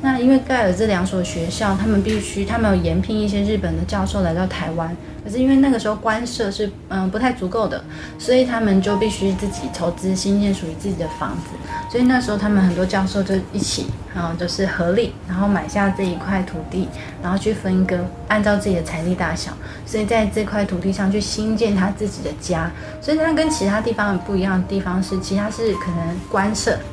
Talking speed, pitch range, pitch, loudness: 335 characters per minute, 180-215 Hz, 195 Hz, -20 LUFS